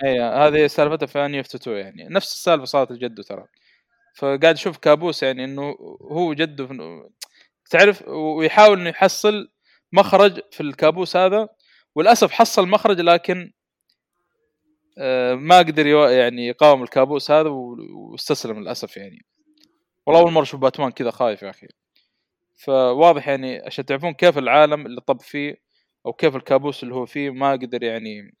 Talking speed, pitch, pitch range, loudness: 140 wpm, 150 Hz, 135-185 Hz, -18 LUFS